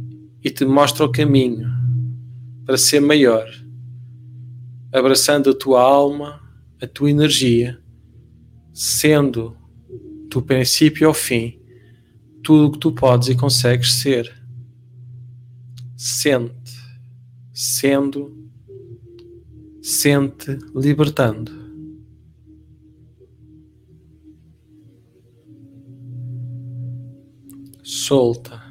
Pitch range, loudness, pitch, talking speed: 120-140 Hz, -16 LUFS, 125 Hz, 70 wpm